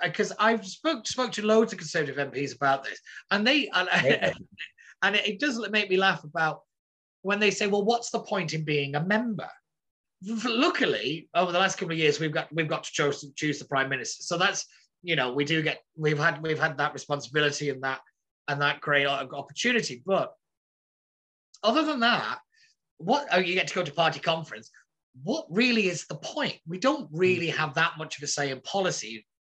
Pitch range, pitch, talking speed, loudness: 145-210 Hz, 170 Hz, 200 wpm, -27 LUFS